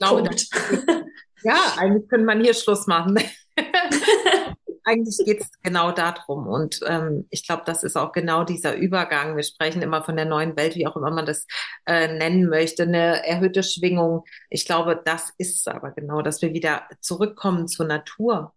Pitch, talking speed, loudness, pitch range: 170 Hz, 180 wpm, -22 LUFS, 160-200 Hz